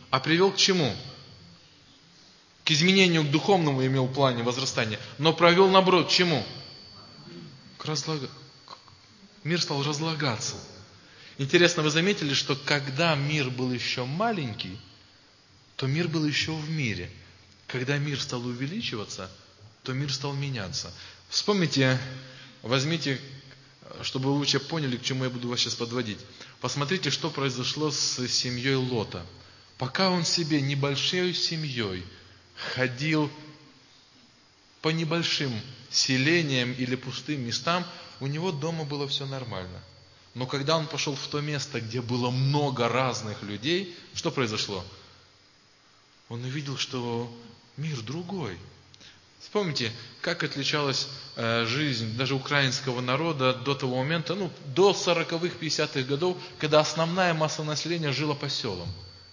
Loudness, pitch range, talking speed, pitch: -27 LUFS, 120-155 Hz, 125 wpm, 135 Hz